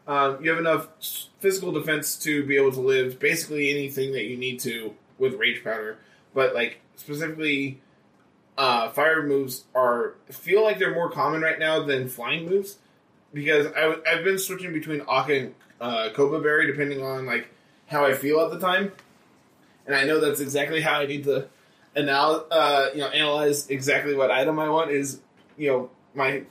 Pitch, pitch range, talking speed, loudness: 145 Hz, 135-160 Hz, 180 wpm, -24 LUFS